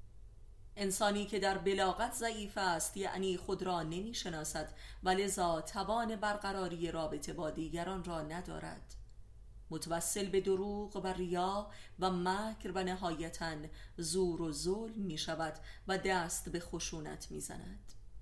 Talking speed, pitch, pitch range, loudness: 125 wpm, 180 Hz, 160-195 Hz, -38 LUFS